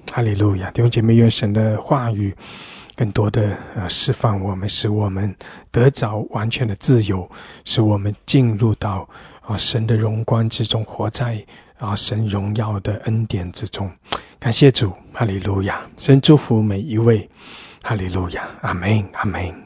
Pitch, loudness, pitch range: 110 Hz, -19 LUFS, 100-115 Hz